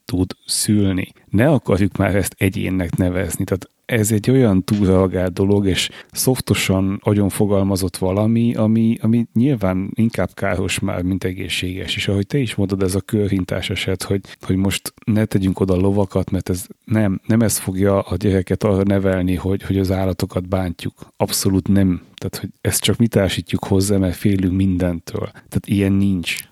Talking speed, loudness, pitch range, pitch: 165 wpm, -19 LUFS, 95-105 Hz, 95 Hz